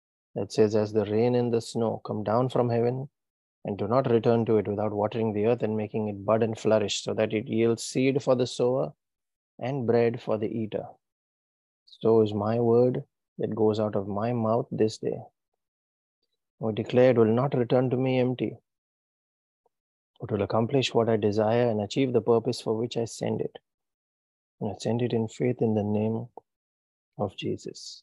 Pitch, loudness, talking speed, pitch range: 110 Hz, -26 LUFS, 185 wpm, 105-120 Hz